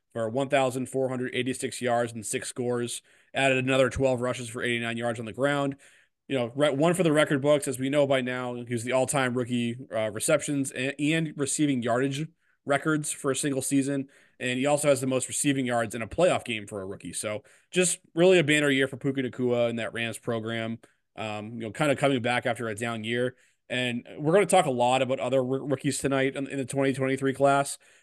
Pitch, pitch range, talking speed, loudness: 130 Hz, 120-140 Hz, 210 wpm, -27 LUFS